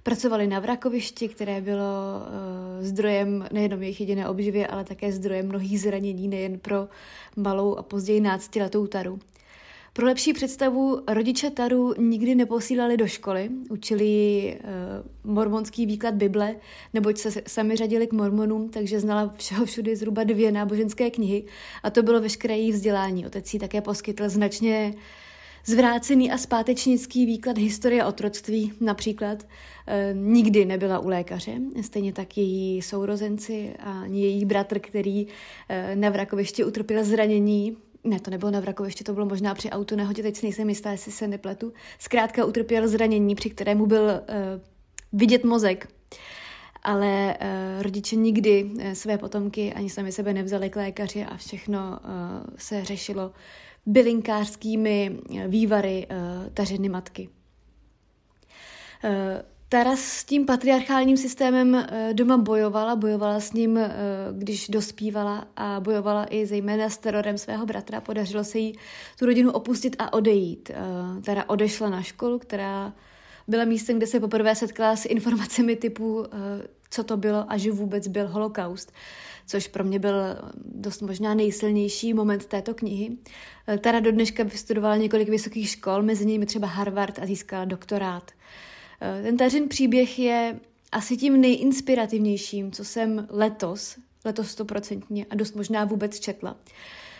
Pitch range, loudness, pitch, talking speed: 200-225 Hz, -25 LUFS, 210 Hz, 135 wpm